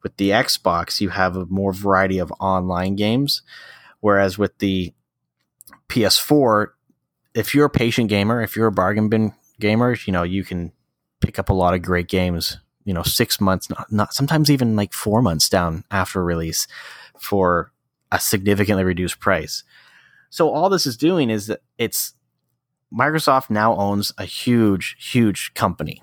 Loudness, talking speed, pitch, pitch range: -19 LUFS, 165 wpm, 100 Hz, 90-115 Hz